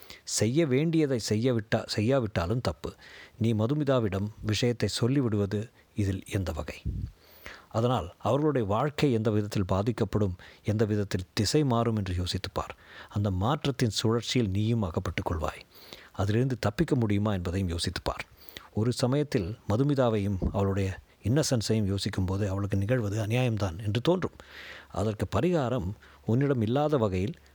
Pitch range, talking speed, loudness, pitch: 100-125 Hz, 115 wpm, -29 LUFS, 110 Hz